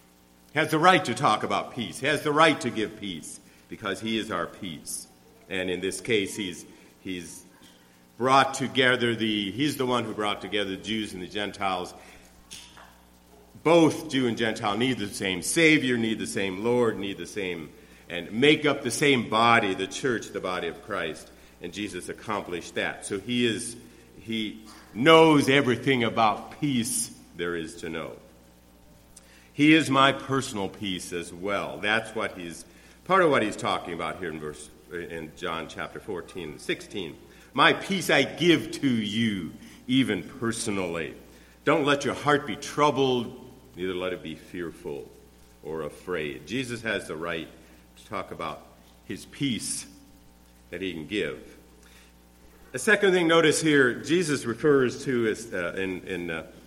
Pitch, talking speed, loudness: 105 Hz, 165 wpm, -26 LUFS